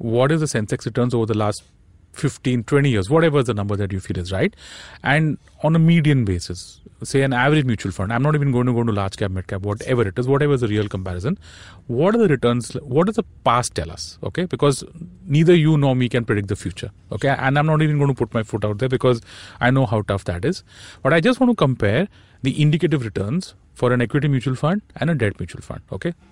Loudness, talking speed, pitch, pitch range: -20 LUFS, 245 wpm, 125 Hz, 105-145 Hz